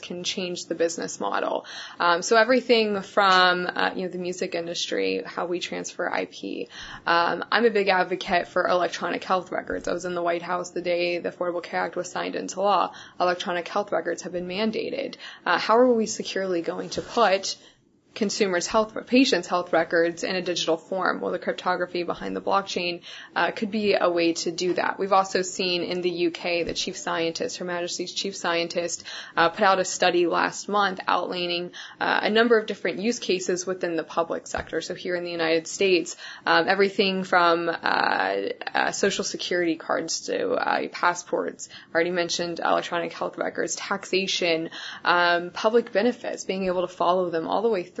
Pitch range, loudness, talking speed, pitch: 170-195 Hz, -25 LUFS, 185 wpm, 180 Hz